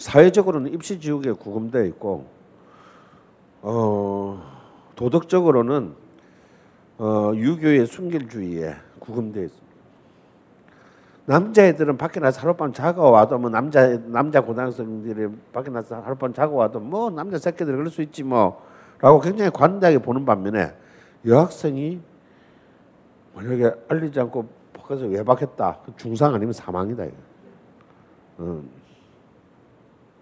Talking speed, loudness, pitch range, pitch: 265 characters per minute, -21 LUFS, 110-155 Hz, 125 Hz